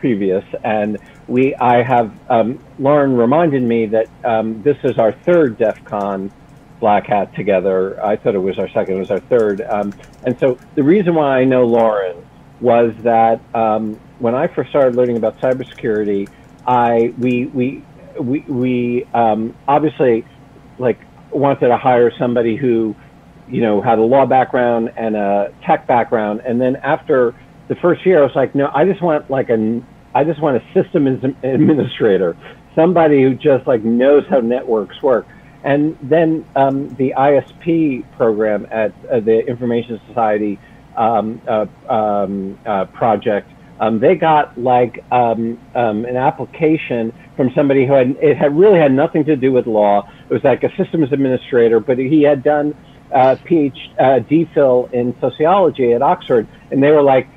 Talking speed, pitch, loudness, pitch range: 165 wpm, 125 Hz, -15 LUFS, 115-140 Hz